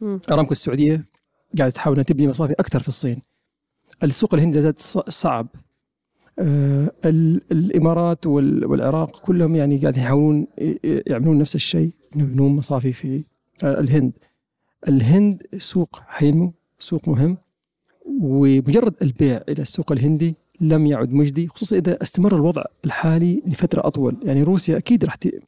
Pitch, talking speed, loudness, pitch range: 155 Hz, 120 wpm, -19 LUFS, 140-170 Hz